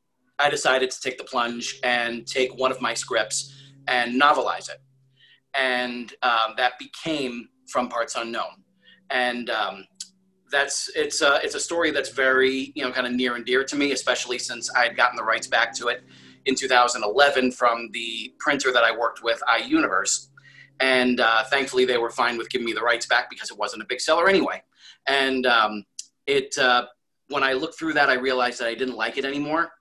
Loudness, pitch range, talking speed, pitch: -23 LUFS, 120-140 Hz, 195 wpm, 130 Hz